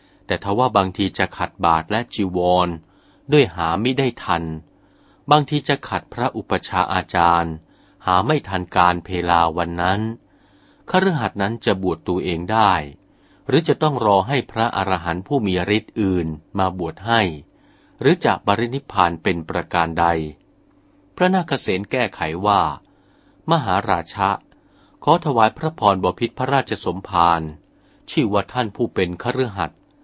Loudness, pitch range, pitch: -20 LUFS, 85-120 Hz, 95 Hz